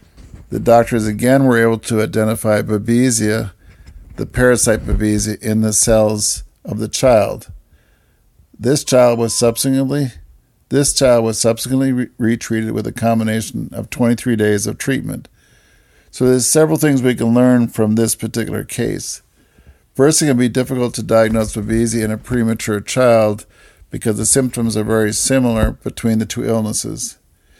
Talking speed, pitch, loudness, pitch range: 145 wpm, 115 Hz, -15 LUFS, 110-125 Hz